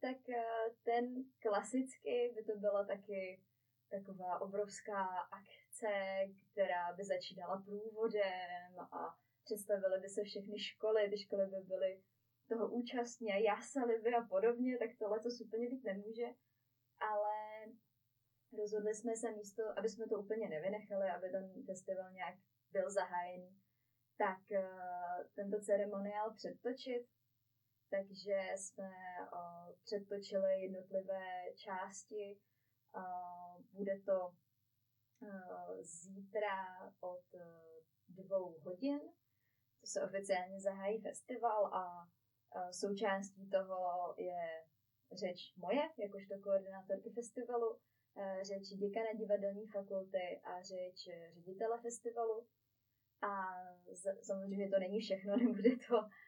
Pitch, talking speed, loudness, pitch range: 195 Hz, 110 wpm, -42 LUFS, 180-215 Hz